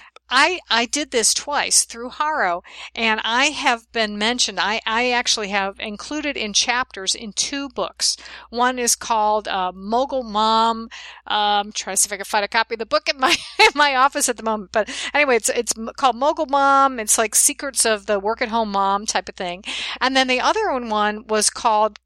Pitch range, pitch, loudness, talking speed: 215-265 Hz, 230 Hz, -19 LUFS, 205 wpm